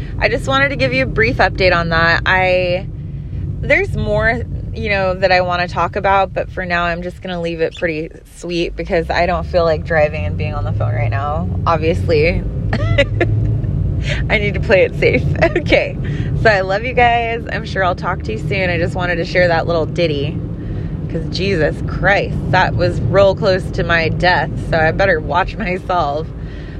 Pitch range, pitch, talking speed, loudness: 130-180 Hz, 165 Hz, 200 wpm, -16 LUFS